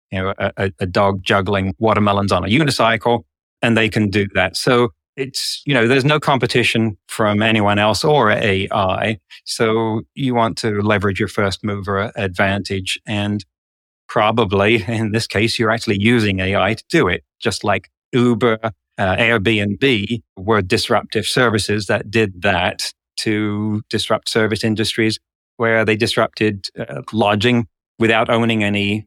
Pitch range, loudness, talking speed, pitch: 100-115 Hz, -17 LUFS, 145 wpm, 110 Hz